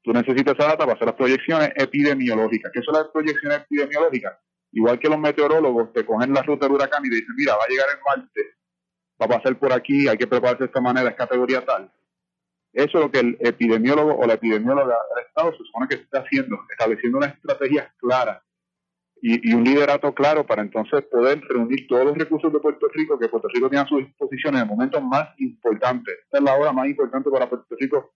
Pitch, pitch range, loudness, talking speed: 140 Hz, 125-155 Hz, -21 LUFS, 220 wpm